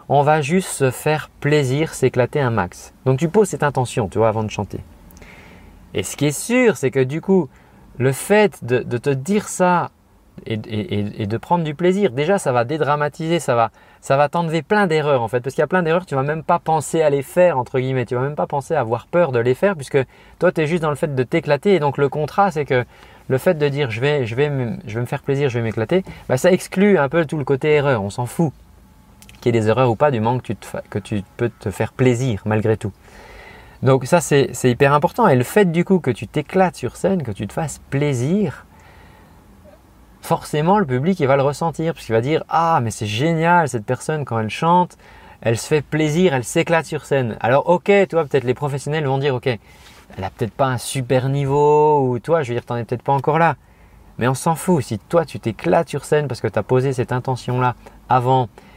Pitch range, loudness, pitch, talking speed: 120-165 Hz, -19 LUFS, 140 Hz, 245 wpm